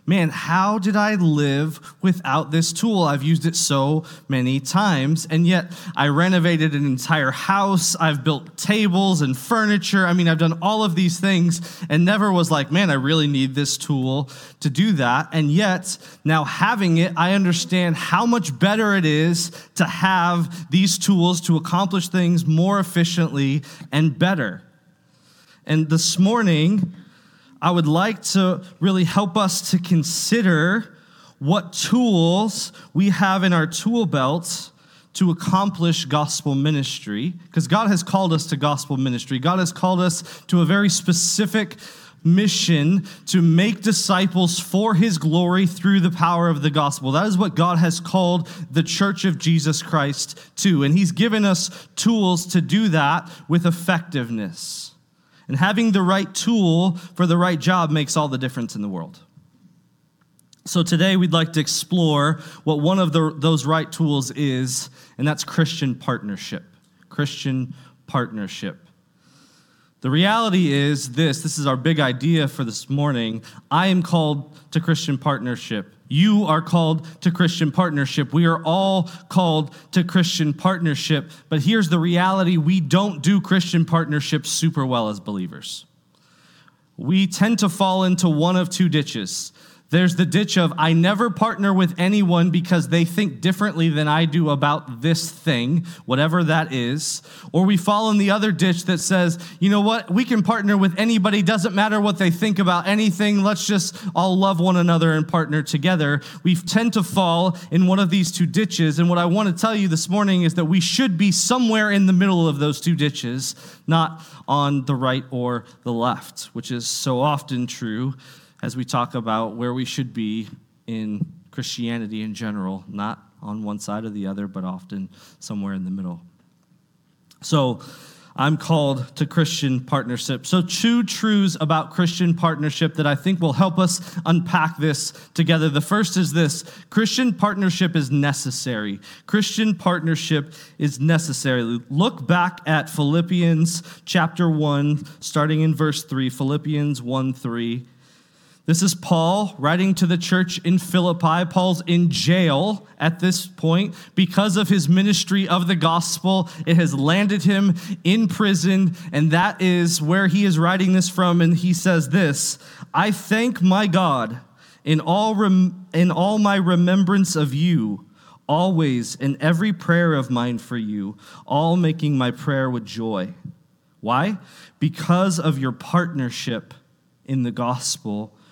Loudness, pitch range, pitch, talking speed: -20 LUFS, 150-185 Hz, 170 Hz, 160 wpm